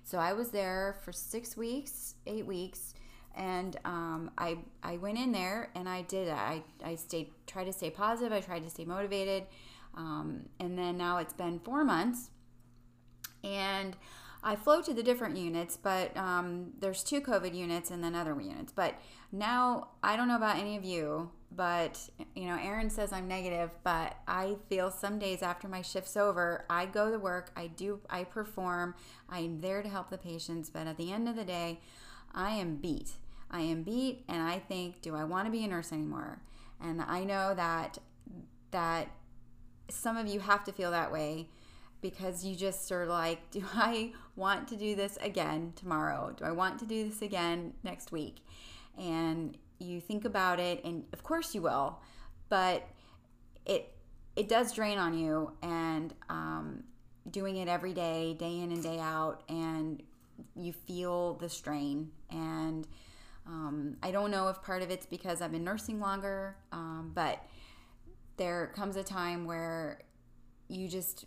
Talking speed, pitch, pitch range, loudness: 175 wpm, 180 Hz, 165-200 Hz, -36 LUFS